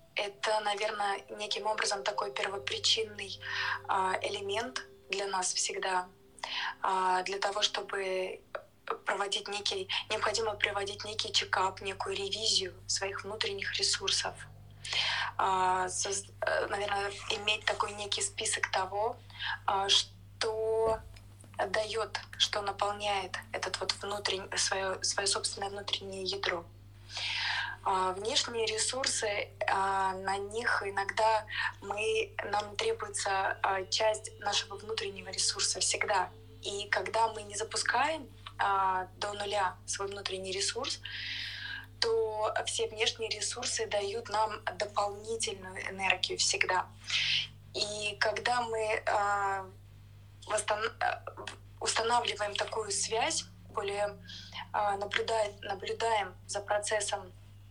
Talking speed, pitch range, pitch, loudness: 90 wpm, 190-220 Hz, 205 Hz, -32 LUFS